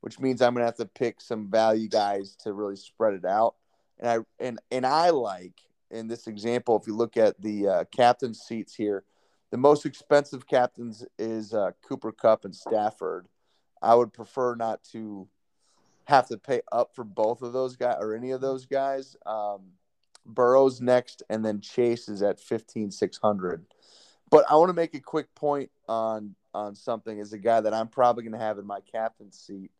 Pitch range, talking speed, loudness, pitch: 105-125 Hz, 195 wpm, -26 LUFS, 115 Hz